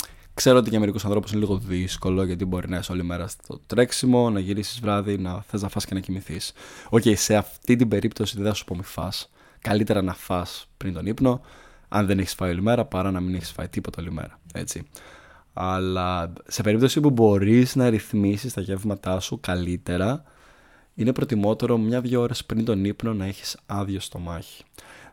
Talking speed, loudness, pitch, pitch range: 190 wpm, -24 LUFS, 100 Hz, 95-110 Hz